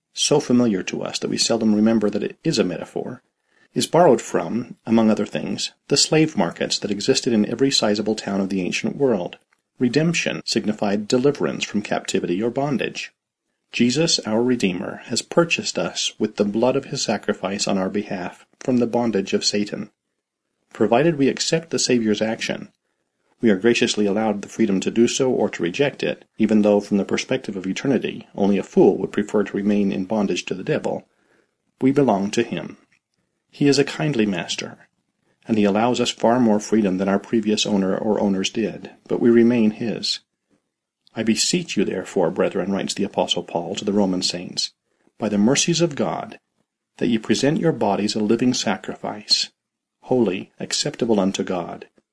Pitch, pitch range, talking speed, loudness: 110 Hz, 100-125 Hz, 175 wpm, -21 LUFS